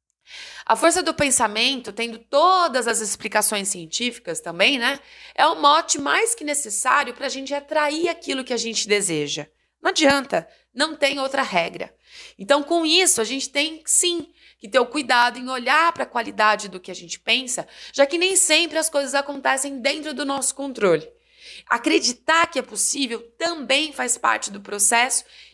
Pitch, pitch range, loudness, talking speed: 275 Hz, 230-310 Hz, -20 LUFS, 175 wpm